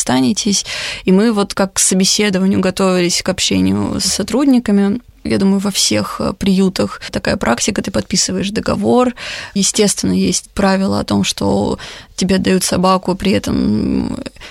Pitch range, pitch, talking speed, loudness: 185-200 Hz, 190 Hz, 135 wpm, -15 LUFS